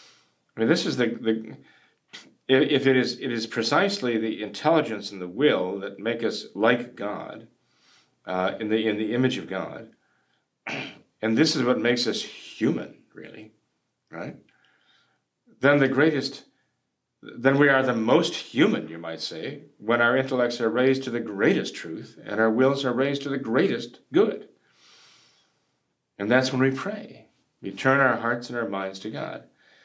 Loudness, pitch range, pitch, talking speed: -24 LUFS, 110-135 Hz, 120 Hz, 165 wpm